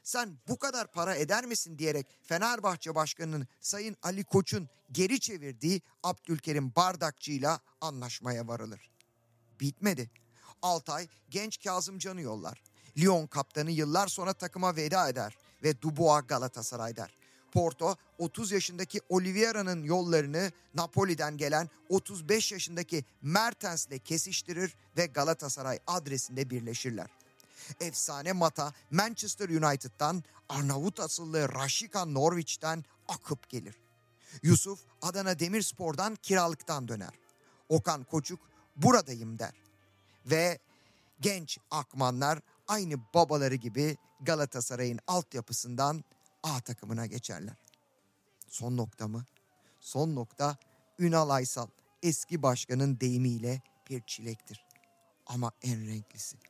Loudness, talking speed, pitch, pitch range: -32 LUFS, 100 wpm, 150 Hz, 125-175 Hz